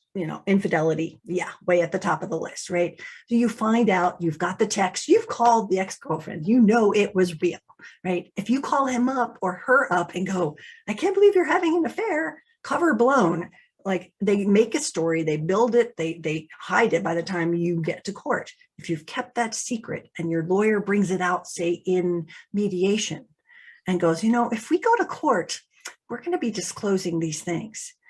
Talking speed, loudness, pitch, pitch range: 210 wpm, -24 LUFS, 190 Hz, 175-235 Hz